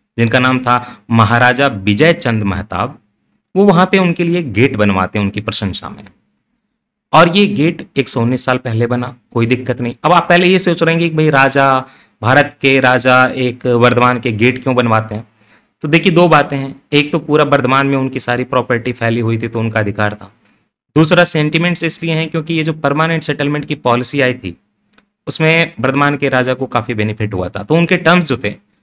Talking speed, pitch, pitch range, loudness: 205 wpm, 130 Hz, 115-160 Hz, -13 LUFS